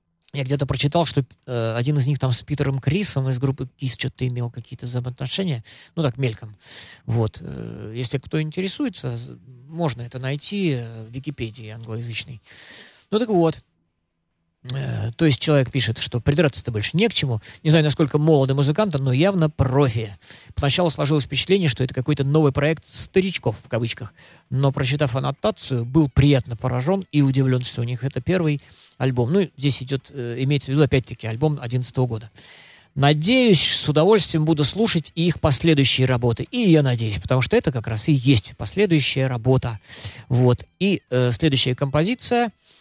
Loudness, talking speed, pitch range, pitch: -20 LUFS, 155 wpm, 120-155 Hz, 135 Hz